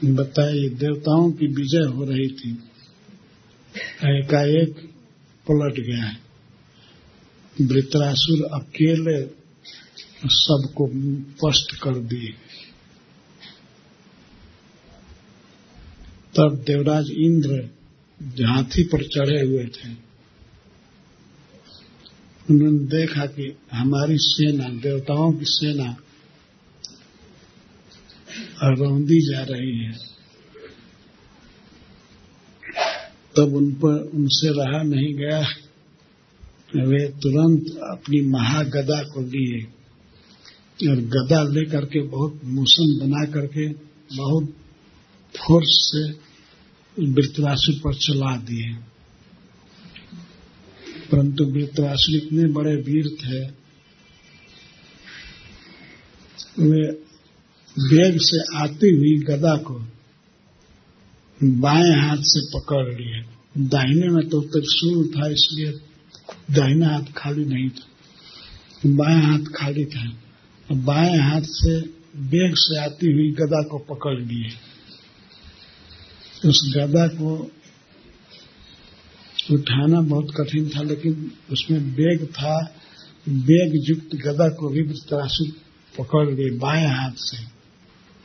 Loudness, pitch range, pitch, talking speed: -20 LUFS, 135-155 Hz, 145 Hz, 90 wpm